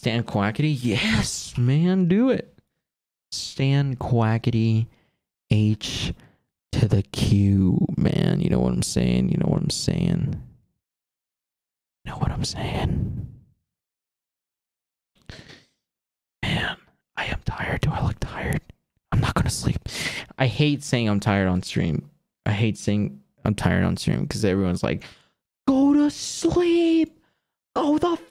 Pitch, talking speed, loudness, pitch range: 115 Hz, 135 wpm, -23 LUFS, 100-150 Hz